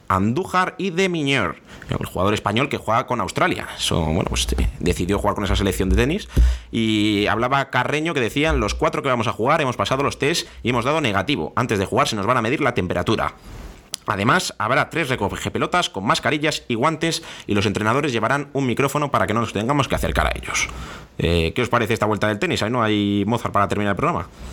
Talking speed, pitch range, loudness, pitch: 220 wpm, 100-140 Hz, -21 LUFS, 105 Hz